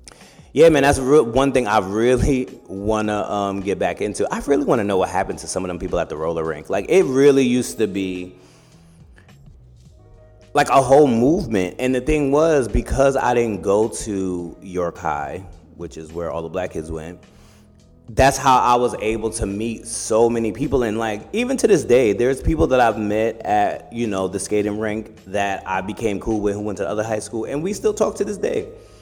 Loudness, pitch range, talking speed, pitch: -19 LUFS, 95-125 Hz, 215 wpm, 110 Hz